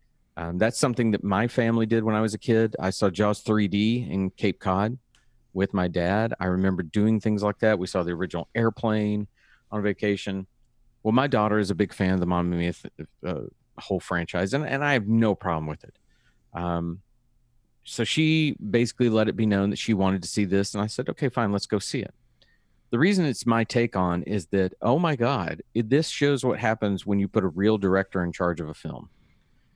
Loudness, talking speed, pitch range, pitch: -25 LUFS, 215 wpm, 95-115 Hz, 105 Hz